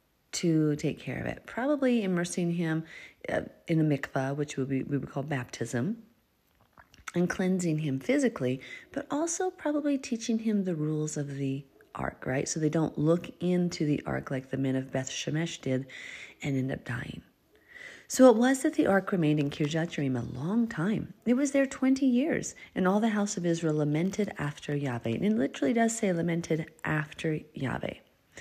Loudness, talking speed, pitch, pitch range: -30 LUFS, 180 wpm, 165 Hz, 145-225 Hz